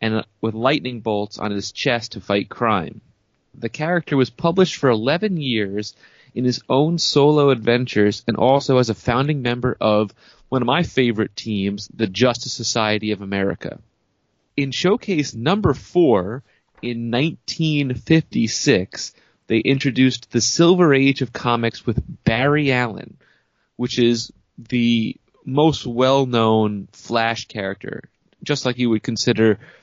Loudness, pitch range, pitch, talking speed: -19 LUFS, 110-140 Hz, 120 Hz, 135 wpm